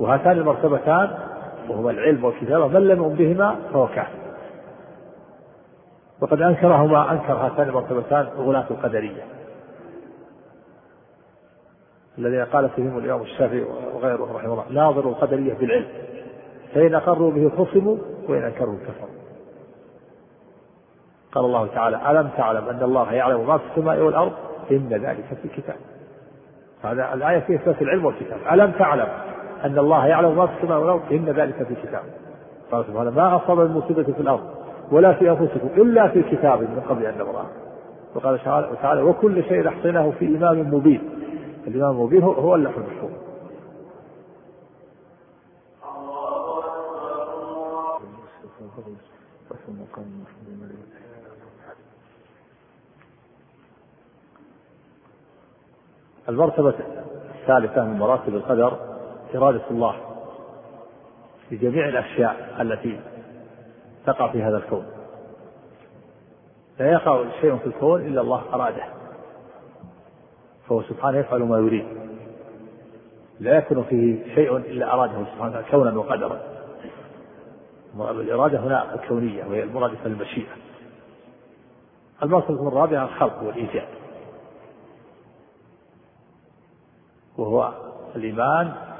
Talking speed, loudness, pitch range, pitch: 100 wpm, -21 LUFS, 120-160 Hz, 140 Hz